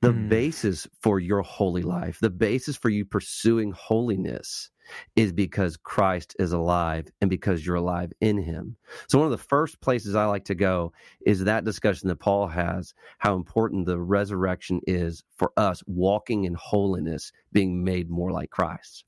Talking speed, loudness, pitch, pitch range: 170 wpm, -26 LUFS, 100 Hz, 90-110 Hz